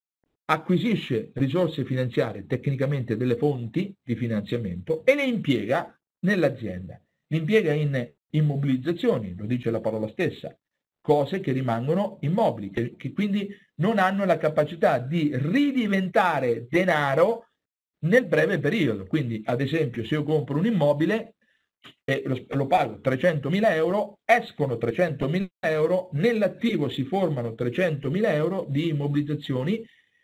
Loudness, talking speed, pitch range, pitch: -25 LUFS, 125 wpm, 130-185 Hz, 155 Hz